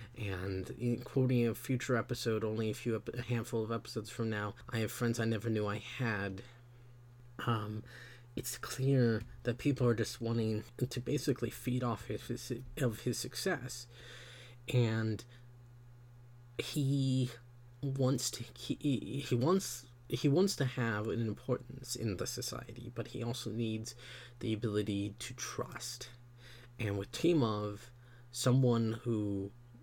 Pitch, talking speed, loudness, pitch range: 120 Hz, 140 wpm, -36 LUFS, 115-125 Hz